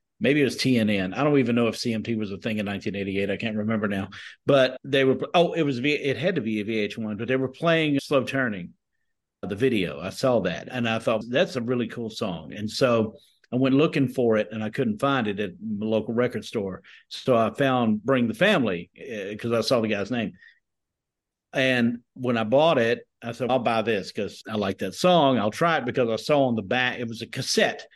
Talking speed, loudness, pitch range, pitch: 230 wpm, -24 LUFS, 110-135 Hz, 120 Hz